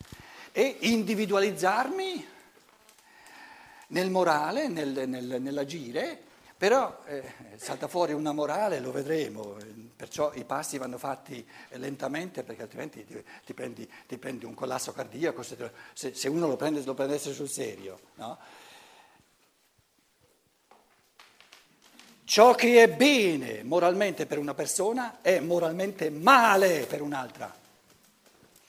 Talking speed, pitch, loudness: 115 wpm, 165 Hz, -27 LUFS